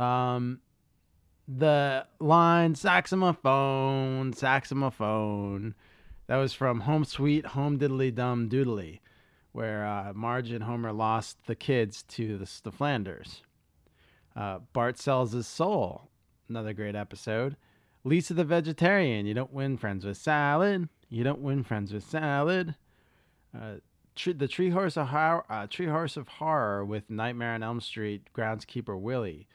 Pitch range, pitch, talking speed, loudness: 110-145 Hz, 125 Hz, 140 wpm, -29 LUFS